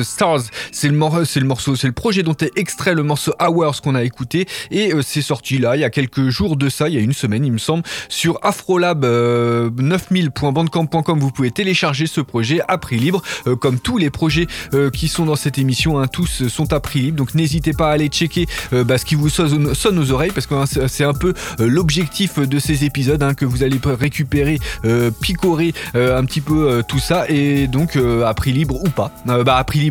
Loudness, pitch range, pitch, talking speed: -17 LUFS, 130-160 Hz, 145 Hz, 240 wpm